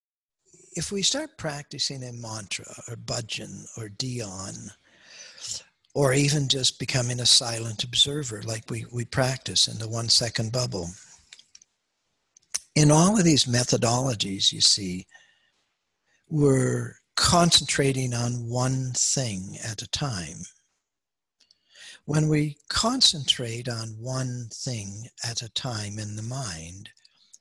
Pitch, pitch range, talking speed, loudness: 125 Hz, 115-140 Hz, 115 wpm, -24 LUFS